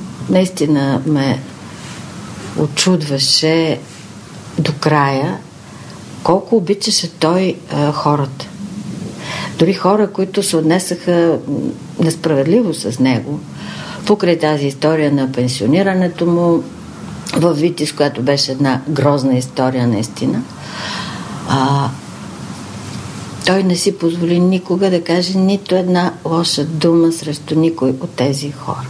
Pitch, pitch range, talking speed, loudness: 160 Hz, 140-180 Hz, 100 wpm, -15 LUFS